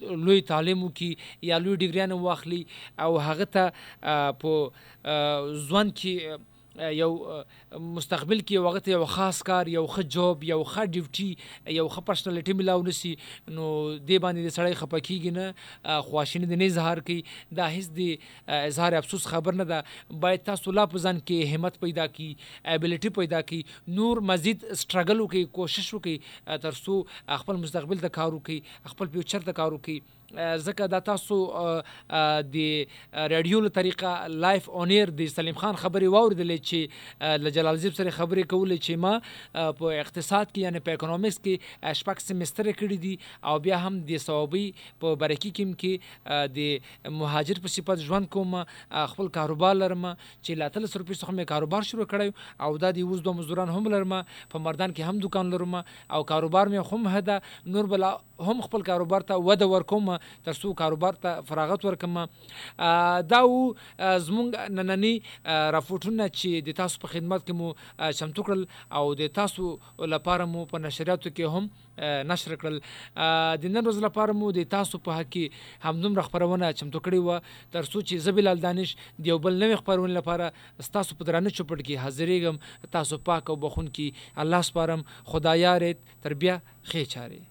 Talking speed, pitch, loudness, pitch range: 145 wpm, 175 Hz, -27 LUFS, 155-190 Hz